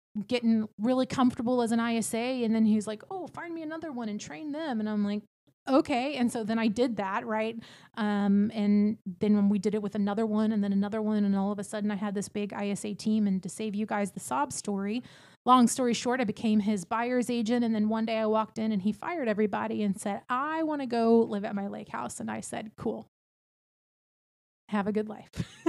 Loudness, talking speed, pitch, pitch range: -29 LUFS, 235 wpm, 220 Hz, 210-240 Hz